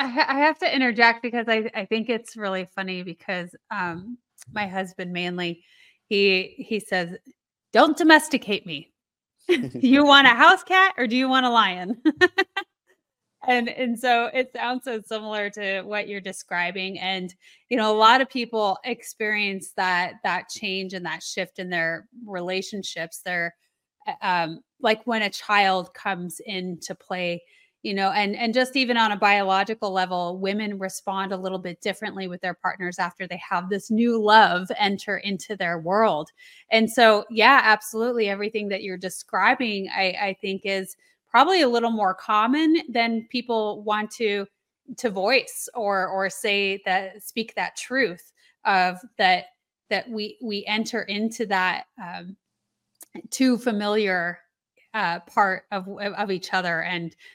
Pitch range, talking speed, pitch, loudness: 190-240 Hz, 155 wpm, 205 Hz, -23 LUFS